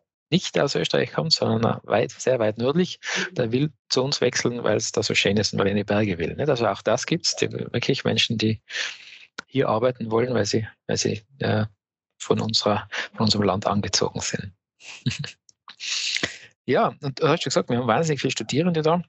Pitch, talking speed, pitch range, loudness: 115 Hz, 190 wpm, 105-135 Hz, -23 LUFS